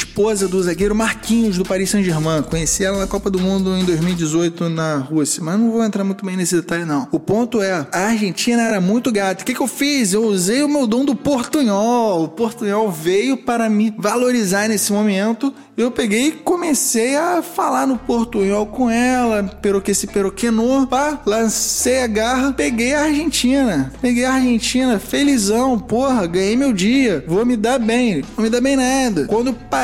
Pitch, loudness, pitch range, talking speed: 225 Hz, -17 LUFS, 195-250 Hz, 190 wpm